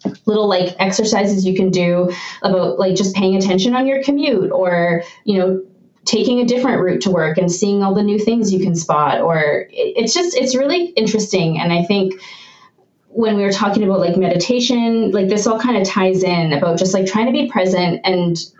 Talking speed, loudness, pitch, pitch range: 205 wpm, -16 LUFS, 195 Hz, 185-225 Hz